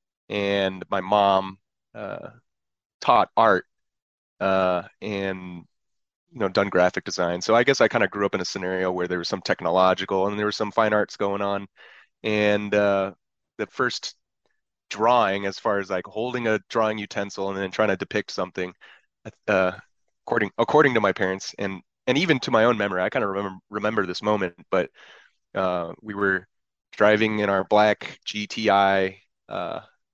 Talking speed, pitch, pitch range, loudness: 170 wpm, 100 Hz, 95-105 Hz, -23 LUFS